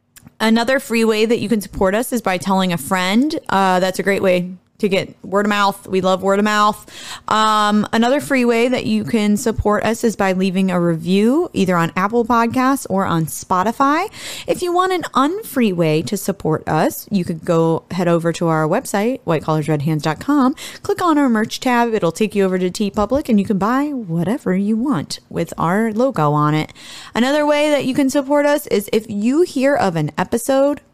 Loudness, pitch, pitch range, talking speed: -17 LUFS, 210 Hz, 185-255 Hz, 200 wpm